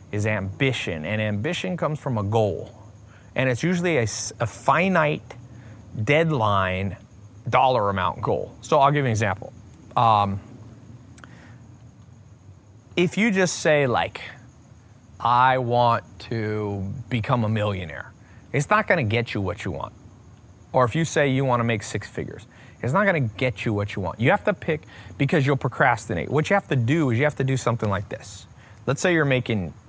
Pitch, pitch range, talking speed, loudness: 115 Hz, 105-135 Hz, 175 wpm, -23 LUFS